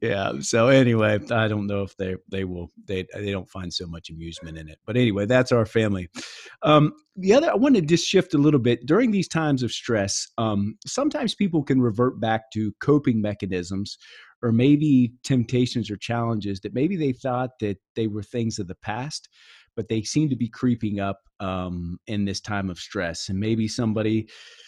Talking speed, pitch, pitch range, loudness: 195 wpm, 110 Hz, 100-130 Hz, -23 LUFS